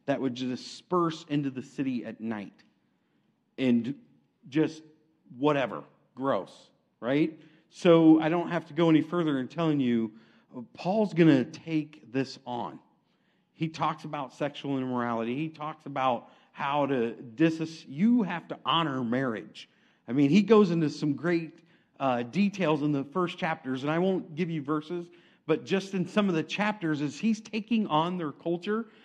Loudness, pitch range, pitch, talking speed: -28 LUFS, 140-175 Hz, 155 Hz, 160 wpm